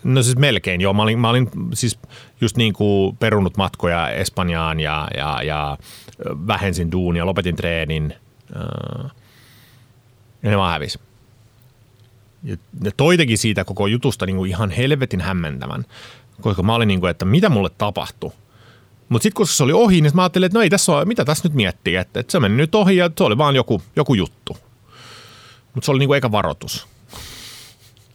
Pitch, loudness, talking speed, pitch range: 115 Hz, -18 LUFS, 175 wpm, 95-125 Hz